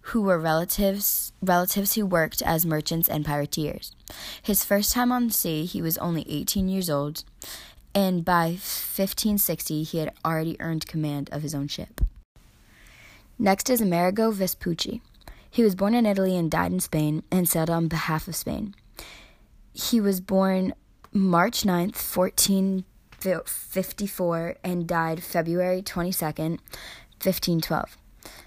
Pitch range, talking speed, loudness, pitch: 160-195 Hz, 145 wpm, -25 LUFS, 180 Hz